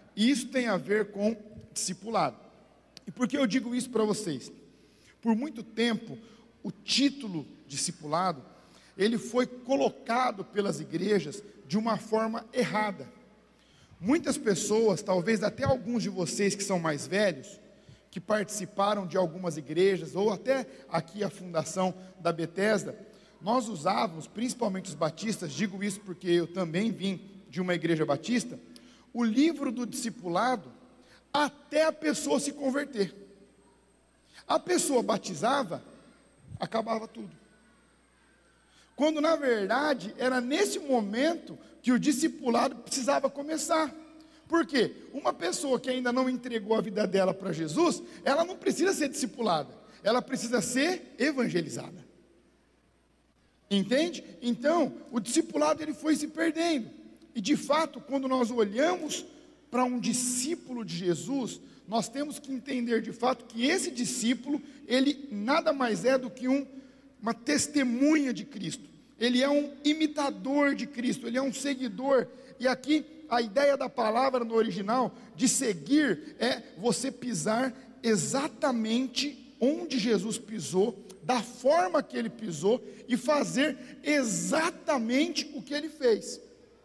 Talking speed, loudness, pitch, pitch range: 135 wpm, -29 LUFS, 245 Hz, 205-280 Hz